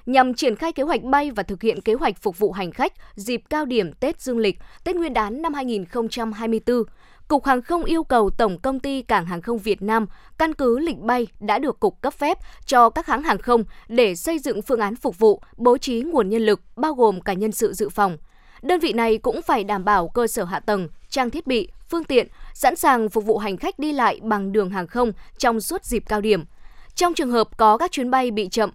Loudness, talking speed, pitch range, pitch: -21 LUFS, 240 wpm, 210-270 Hz, 235 Hz